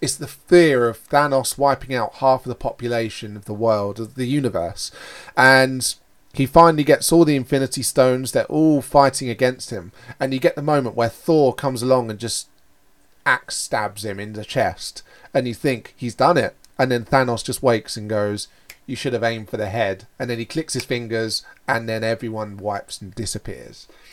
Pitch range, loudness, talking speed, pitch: 110-135 Hz, -20 LUFS, 195 wpm, 125 Hz